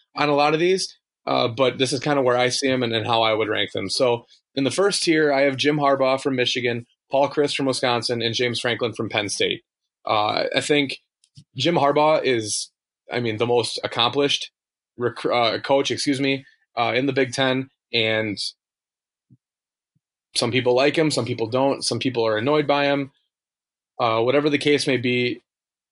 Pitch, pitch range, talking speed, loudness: 130 Hz, 120-145 Hz, 195 wpm, -21 LUFS